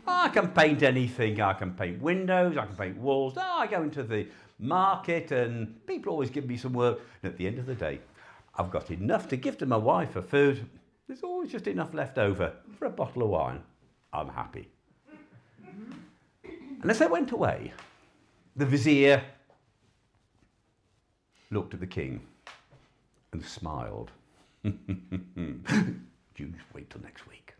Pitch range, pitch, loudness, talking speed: 105-170 Hz, 130 Hz, -29 LUFS, 160 wpm